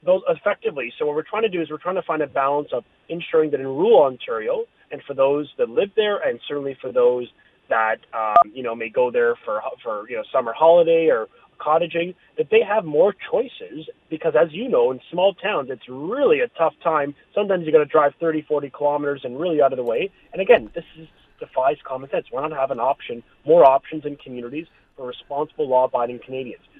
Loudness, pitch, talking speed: -21 LUFS, 170 Hz, 220 wpm